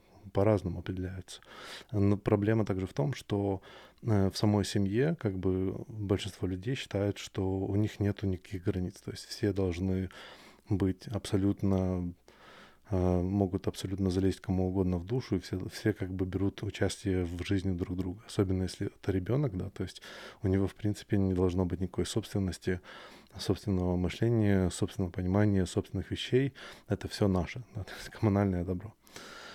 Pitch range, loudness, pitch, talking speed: 95-105 Hz, -32 LUFS, 95 Hz, 155 wpm